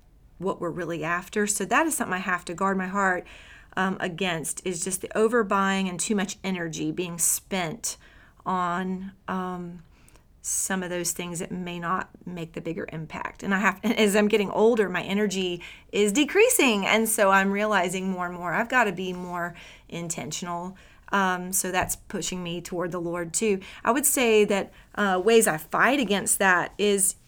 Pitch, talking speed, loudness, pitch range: 185 Hz, 185 wpm, -25 LUFS, 175-205 Hz